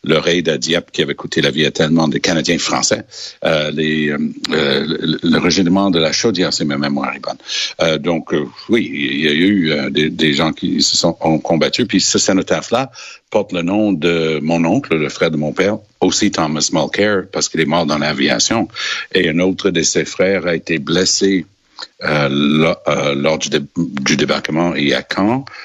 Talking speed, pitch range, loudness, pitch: 205 wpm, 75-90 Hz, -15 LUFS, 80 Hz